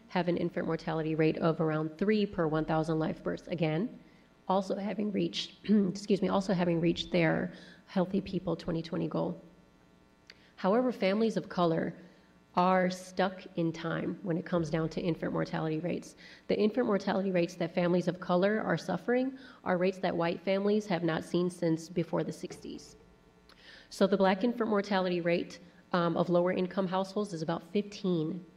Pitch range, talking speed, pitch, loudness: 165-195 Hz, 165 wpm, 180 Hz, -31 LUFS